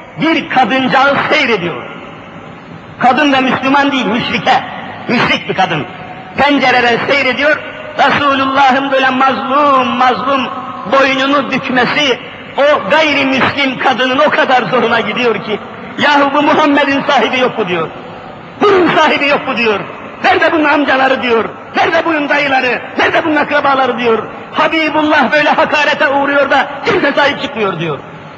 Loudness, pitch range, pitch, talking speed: -11 LUFS, 250-295 Hz, 270 Hz, 125 wpm